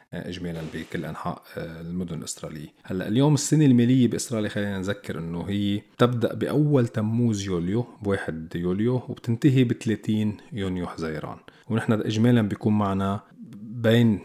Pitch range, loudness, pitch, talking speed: 95-120 Hz, -25 LUFS, 105 Hz, 120 wpm